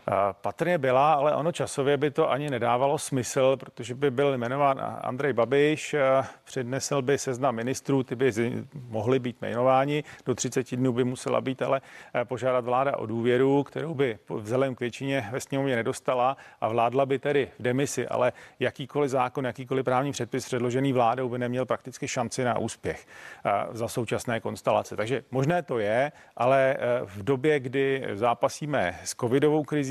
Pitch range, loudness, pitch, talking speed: 125-140 Hz, -27 LUFS, 130 Hz, 160 wpm